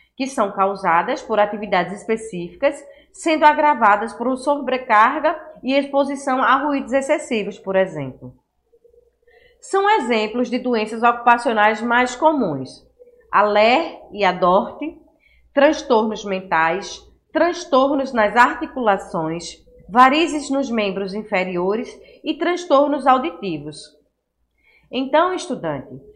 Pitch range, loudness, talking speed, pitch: 200-300 Hz, -18 LUFS, 95 wpm, 250 Hz